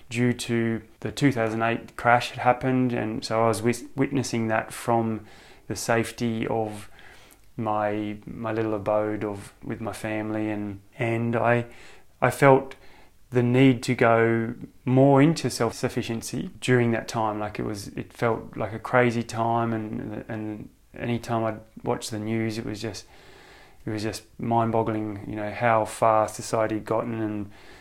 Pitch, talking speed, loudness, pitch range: 115 Hz, 165 wpm, -25 LUFS, 110-120 Hz